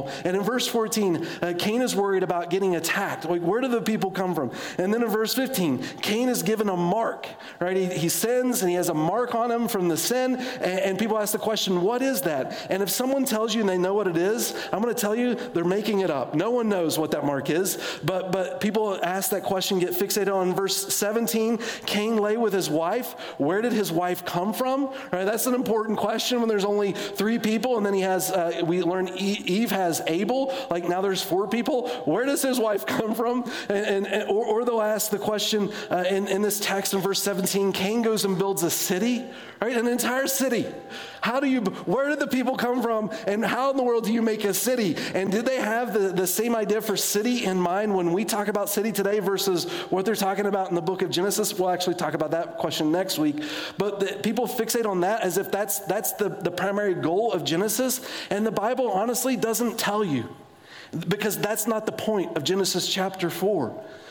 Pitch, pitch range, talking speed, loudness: 205 Hz, 185-230 Hz, 235 wpm, -25 LUFS